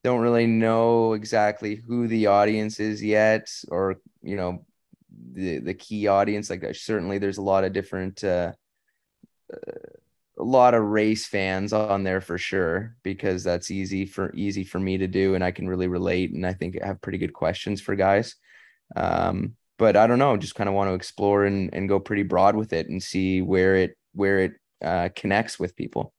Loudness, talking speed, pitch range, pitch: -24 LUFS, 195 wpm, 95-110 Hz, 100 Hz